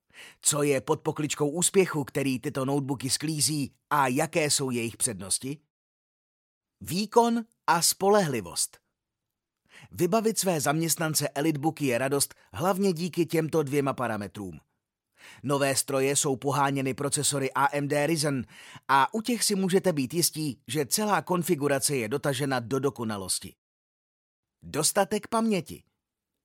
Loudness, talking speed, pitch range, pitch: -26 LUFS, 115 wpm, 135-170 Hz, 145 Hz